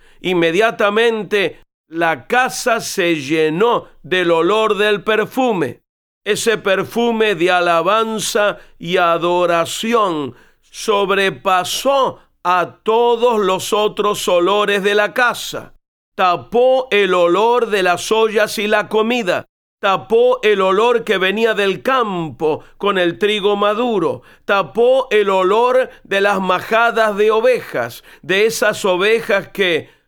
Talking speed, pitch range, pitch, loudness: 110 wpm, 185-230 Hz, 210 Hz, -15 LUFS